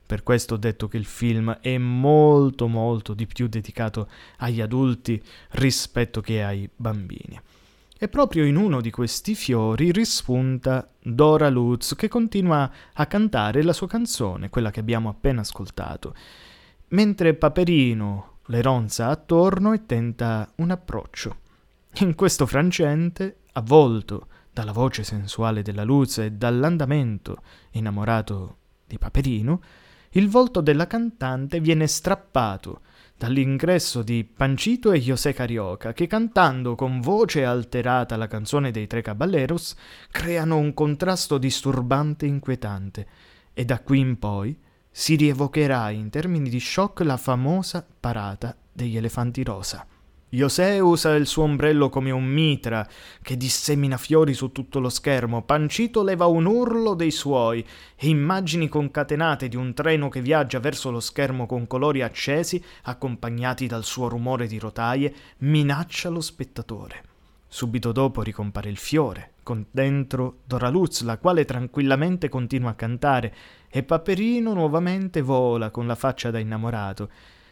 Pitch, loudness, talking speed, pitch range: 130 Hz, -23 LUFS, 135 wpm, 115-155 Hz